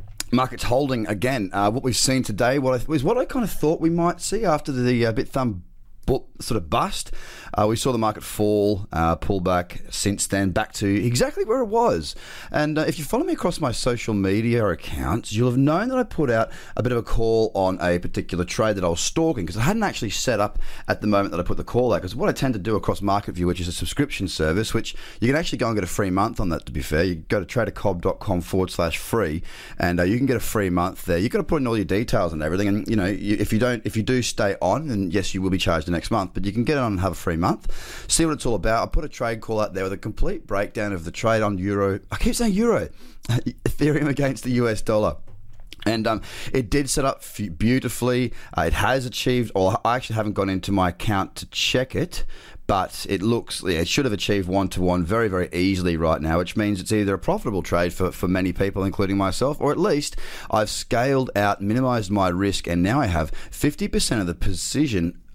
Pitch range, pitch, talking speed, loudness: 95-125 Hz, 105 Hz, 250 wpm, -23 LUFS